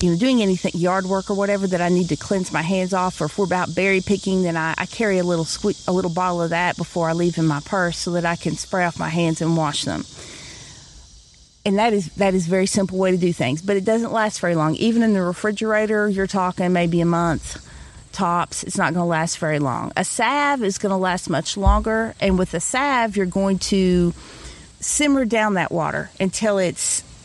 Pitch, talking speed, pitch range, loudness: 185 Hz, 235 wpm, 170-200 Hz, -20 LUFS